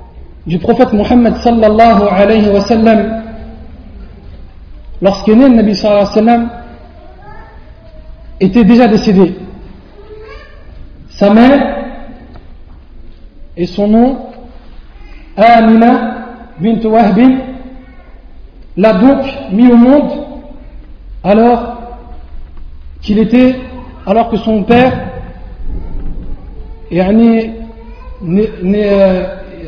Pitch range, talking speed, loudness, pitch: 185-240 Hz, 75 wpm, -9 LUFS, 220 Hz